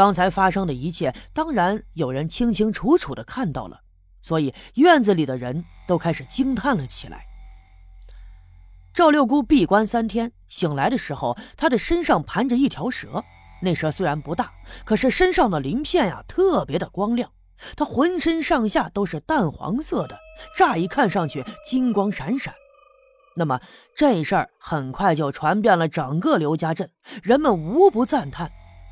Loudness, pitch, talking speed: -21 LUFS, 200 Hz, 245 characters per minute